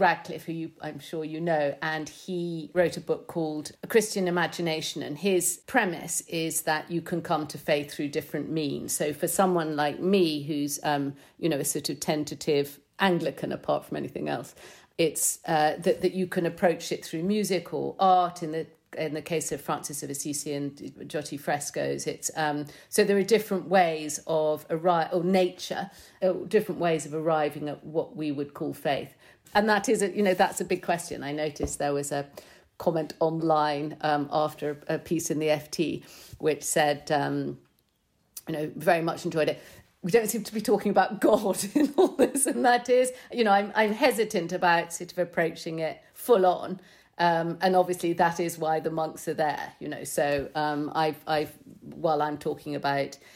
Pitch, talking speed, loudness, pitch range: 160 Hz, 195 wpm, -27 LUFS, 150-180 Hz